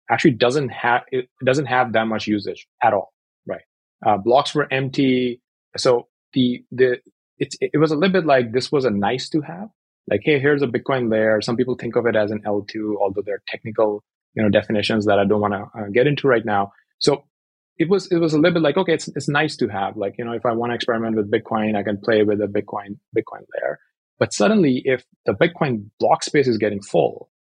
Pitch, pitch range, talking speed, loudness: 120 Hz, 105-145 Hz, 230 wpm, -20 LUFS